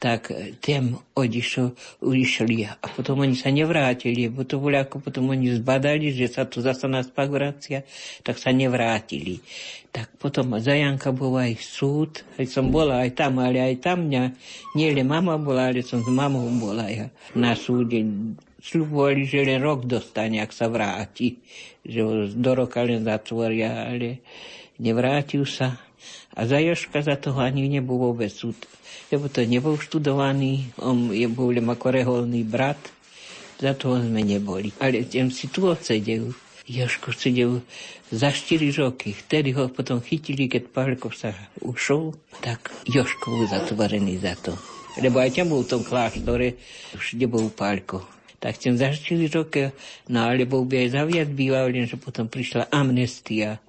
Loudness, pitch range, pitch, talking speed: -24 LUFS, 120-140 Hz, 130 Hz, 155 wpm